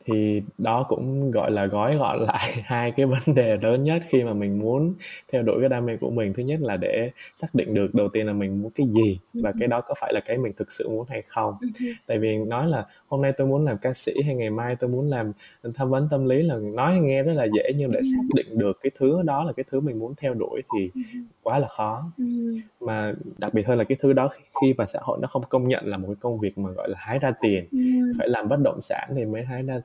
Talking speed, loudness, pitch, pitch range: 270 wpm, -24 LUFS, 130 Hz, 110-150 Hz